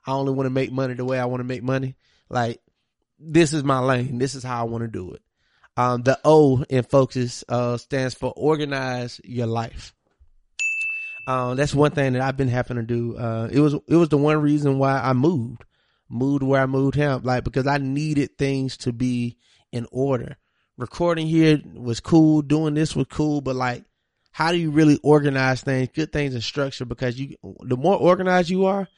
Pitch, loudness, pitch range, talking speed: 135 Hz, -22 LUFS, 125-150 Hz, 205 wpm